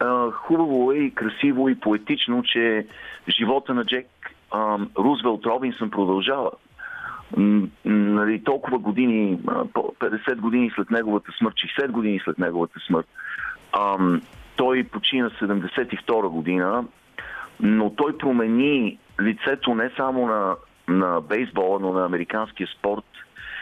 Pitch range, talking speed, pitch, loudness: 100-130 Hz, 110 wpm, 110 Hz, -23 LUFS